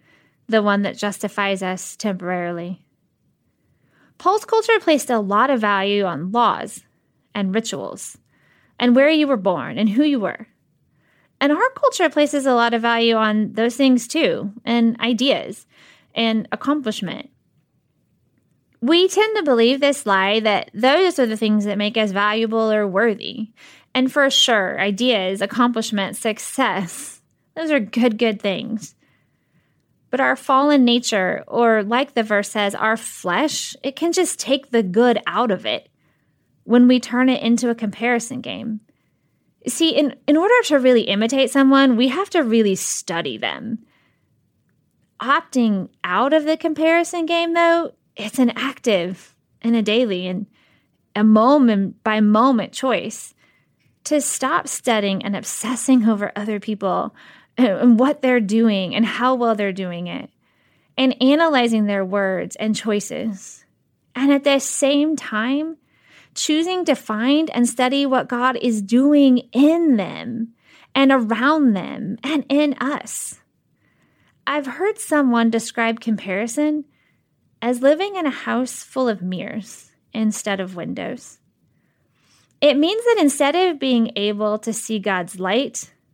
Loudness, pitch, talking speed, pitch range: -19 LUFS, 240 Hz, 140 wpm, 215-275 Hz